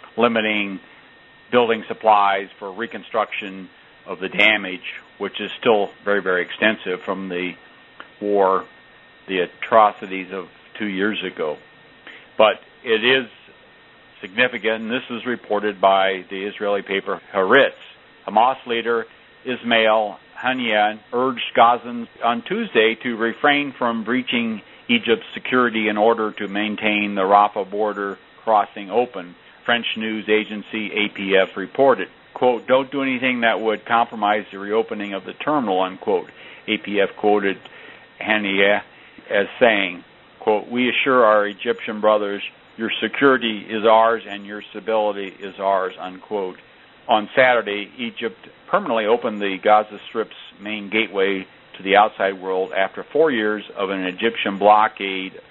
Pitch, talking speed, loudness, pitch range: 105 Hz, 130 wpm, -20 LUFS, 100-115 Hz